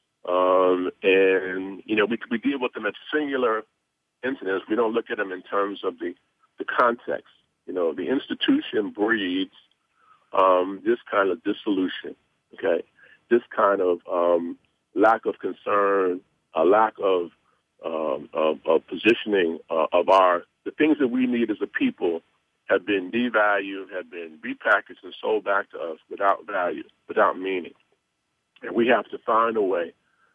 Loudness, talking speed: -24 LUFS, 160 wpm